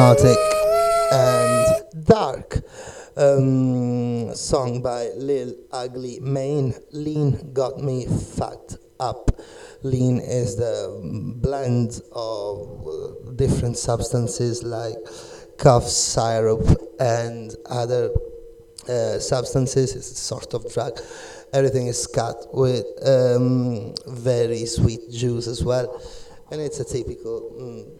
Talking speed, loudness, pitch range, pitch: 100 wpm, -22 LUFS, 120-150 Hz, 125 Hz